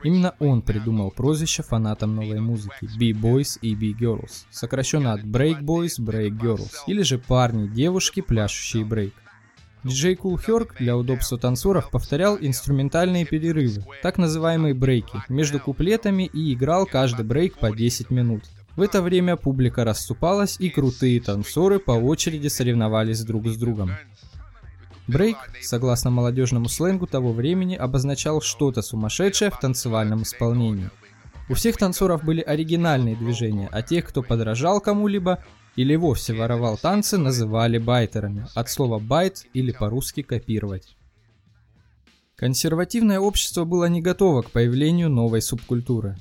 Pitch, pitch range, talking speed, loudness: 125 Hz, 110-165 Hz, 130 wpm, -22 LUFS